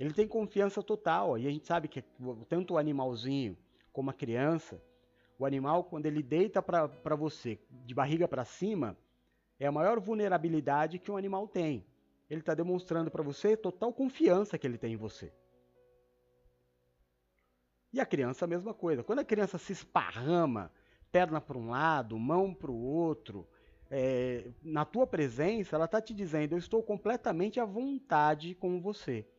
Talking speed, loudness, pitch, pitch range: 165 wpm, -33 LUFS, 155 Hz, 125-180 Hz